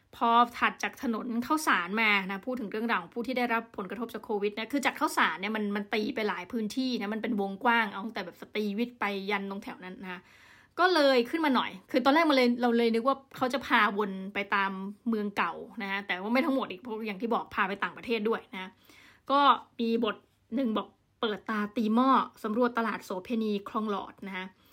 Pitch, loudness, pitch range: 225 Hz, -29 LUFS, 205-245 Hz